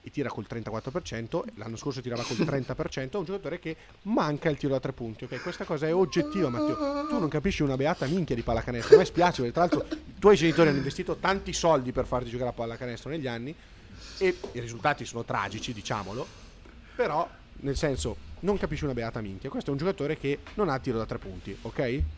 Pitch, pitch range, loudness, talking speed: 135 Hz, 115-170 Hz, -29 LUFS, 210 wpm